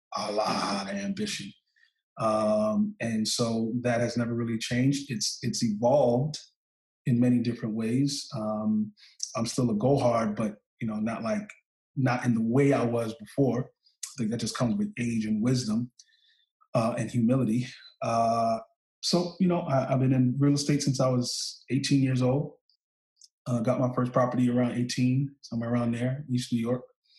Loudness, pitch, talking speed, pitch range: -28 LUFS, 125 Hz, 170 wpm, 115-135 Hz